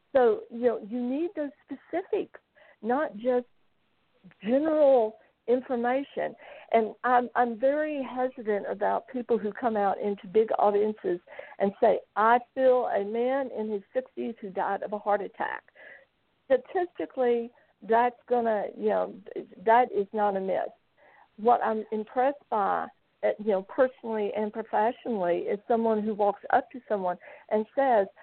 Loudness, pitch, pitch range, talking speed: -28 LUFS, 240 Hz, 215-265 Hz, 140 wpm